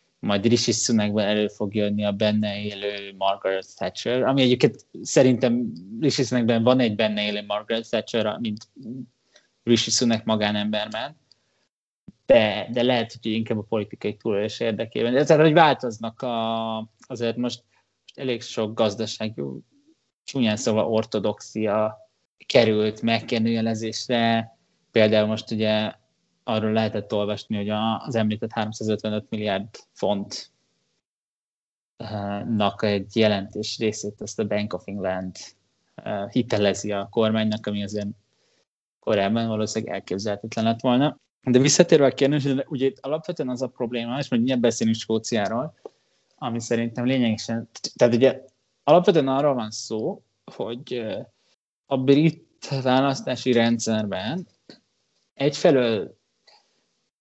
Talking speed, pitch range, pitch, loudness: 115 wpm, 105-125 Hz, 115 Hz, -23 LUFS